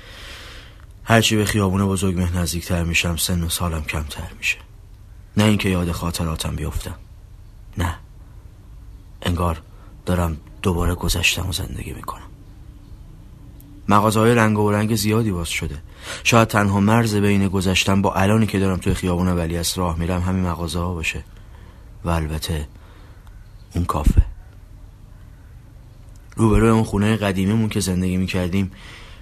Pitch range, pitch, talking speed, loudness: 85-105 Hz, 95 Hz, 125 wpm, -20 LUFS